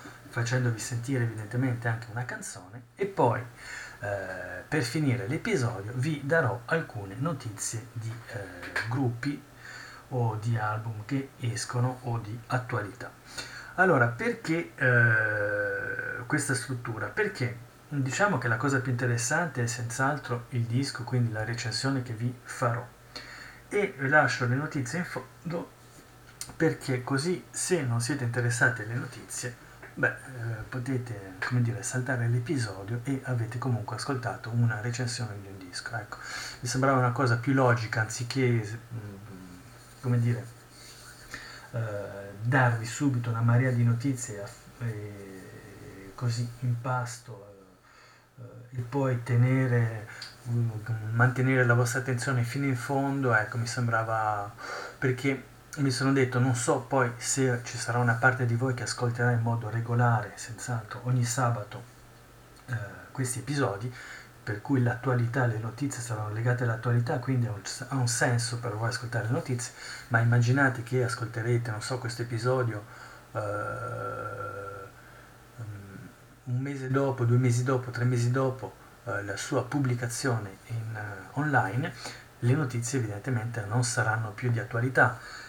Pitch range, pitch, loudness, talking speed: 115-130 Hz, 120 Hz, -29 LUFS, 135 wpm